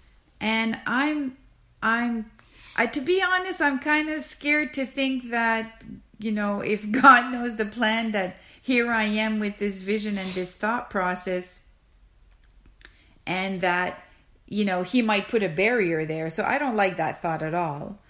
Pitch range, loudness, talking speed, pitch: 190-250 Hz, -24 LUFS, 165 wpm, 220 Hz